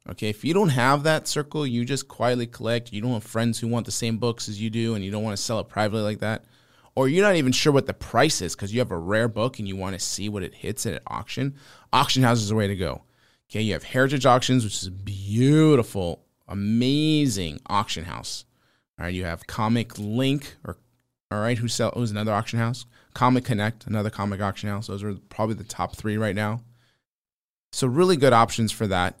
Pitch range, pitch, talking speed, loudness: 100-125 Hz, 110 Hz, 235 wpm, -24 LUFS